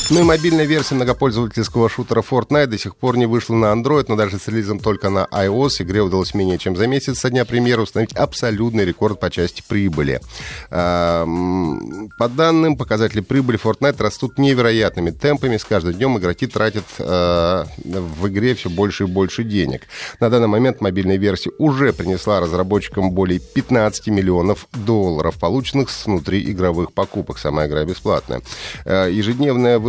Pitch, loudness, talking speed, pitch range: 105 Hz, -18 LUFS, 155 wpm, 95-125 Hz